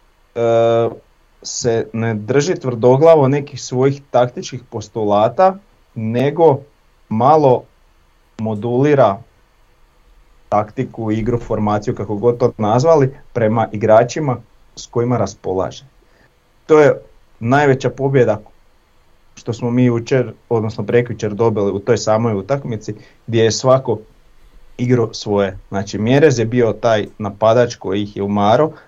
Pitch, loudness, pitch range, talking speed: 115 Hz, -16 LUFS, 105-130 Hz, 110 wpm